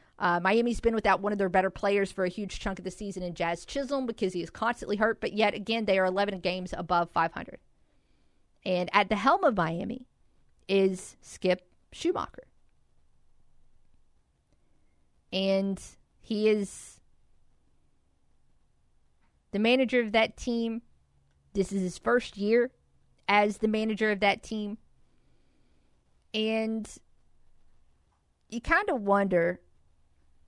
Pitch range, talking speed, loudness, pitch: 180-220 Hz, 130 wpm, -28 LUFS, 200 Hz